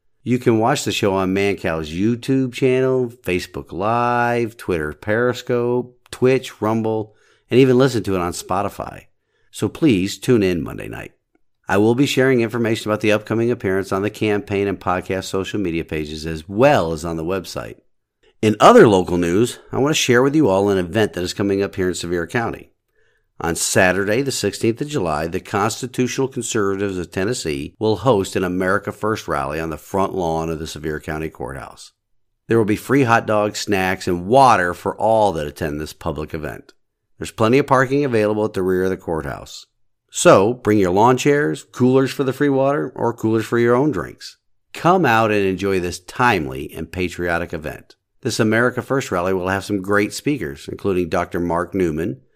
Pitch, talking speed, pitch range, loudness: 105 Hz, 185 wpm, 90-120 Hz, -19 LUFS